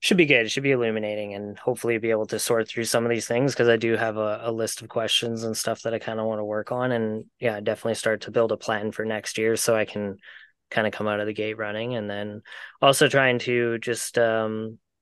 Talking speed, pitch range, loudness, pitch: 265 wpm, 110-115 Hz, -24 LUFS, 110 Hz